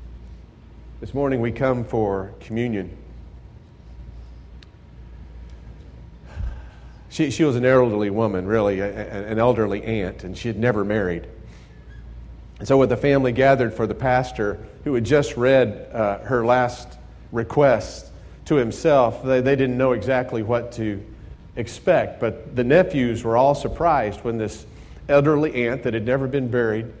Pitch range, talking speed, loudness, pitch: 95-125 Hz, 145 wpm, -21 LUFS, 115 Hz